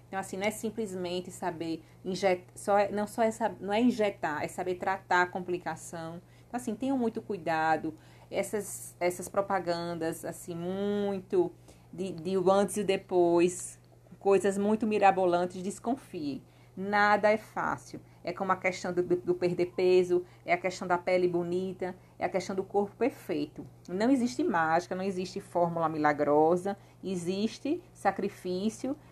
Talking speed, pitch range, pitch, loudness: 150 wpm, 175-205 Hz, 185 Hz, -30 LUFS